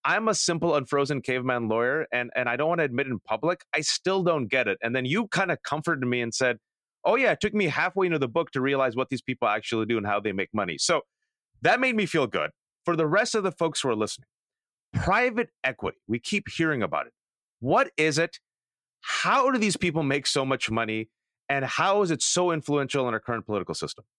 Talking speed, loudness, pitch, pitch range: 235 wpm, -26 LUFS, 145 Hz, 120-175 Hz